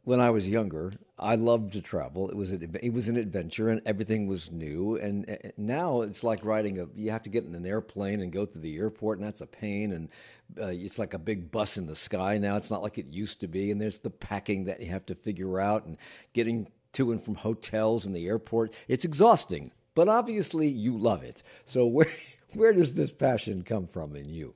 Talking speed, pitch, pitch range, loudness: 230 wpm, 105 Hz, 95-115 Hz, -30 LUFS